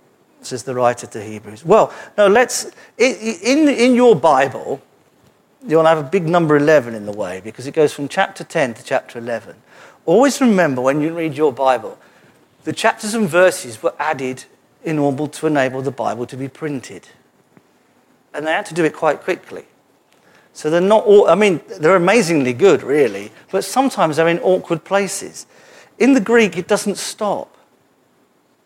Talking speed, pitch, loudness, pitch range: 170 wpm, 165 Hz, -16 LUFS, 140-215 Hz